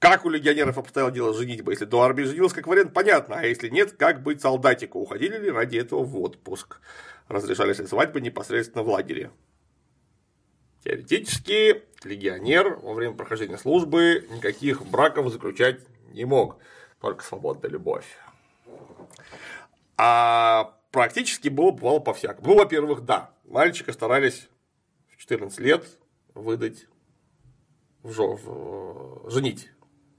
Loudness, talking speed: -23 LUFS, 120 wpm